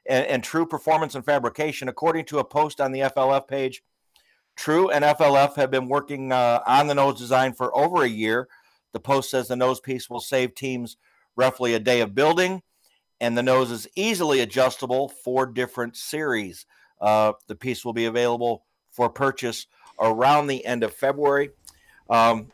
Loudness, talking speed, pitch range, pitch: -23 LUFS, 175 wpm, 120-140 Hz, 130 Hz